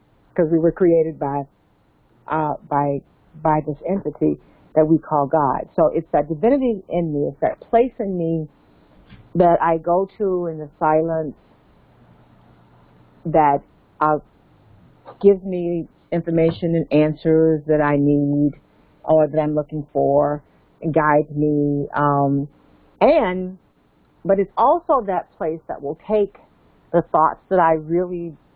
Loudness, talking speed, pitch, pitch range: -20 LUFS, 135 wpm, 155 Hz, 145-170 Hz